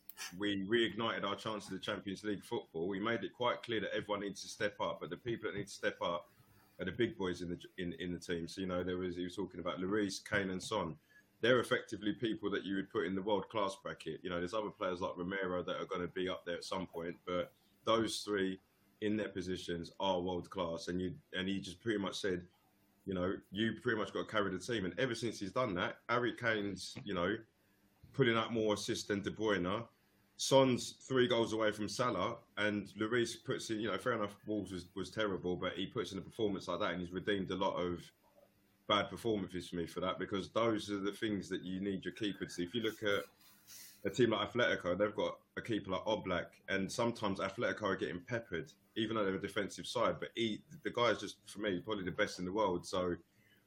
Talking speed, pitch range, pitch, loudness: 240 wpm, 90-110 Hz, 100 Hz, -38 LUFS